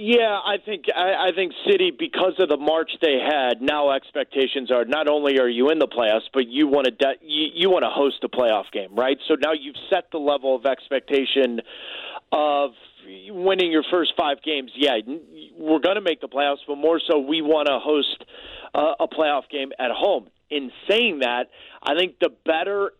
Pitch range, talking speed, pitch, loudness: 135-180 Hz, 205 wpm, 150 Hz, -22 LUFS